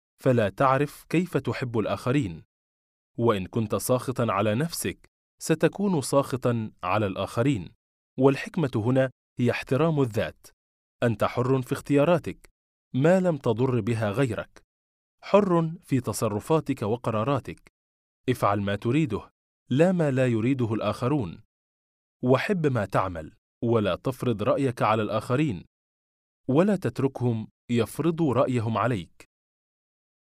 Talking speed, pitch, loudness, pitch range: 105 wpm, 120 Hz, -26 LUFS, 105-140 Hz